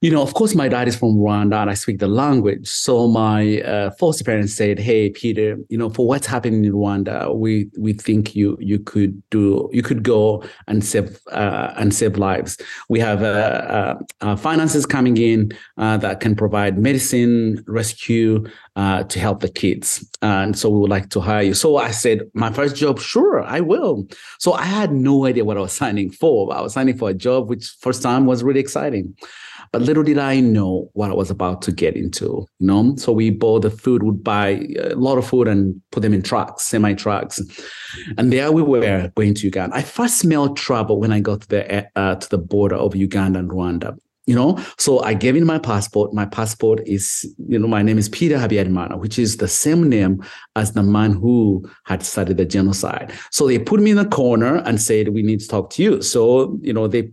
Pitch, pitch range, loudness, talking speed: 110 Hz, 100-125 Hz, -18 LUFS, 220 wpm